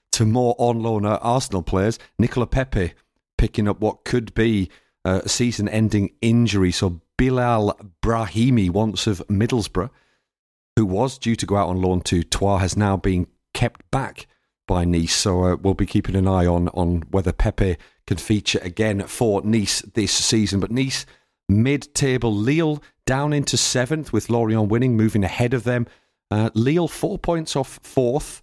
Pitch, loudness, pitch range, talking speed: 110 Hz, -21 LUFS, 95-120 Hz, 170 wpm